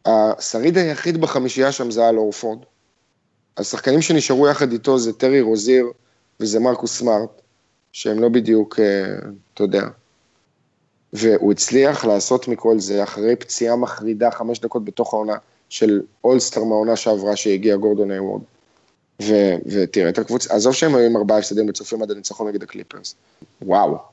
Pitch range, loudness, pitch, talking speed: 105-125 Hz, -18 LUFS, 115 Hz, 140 wpm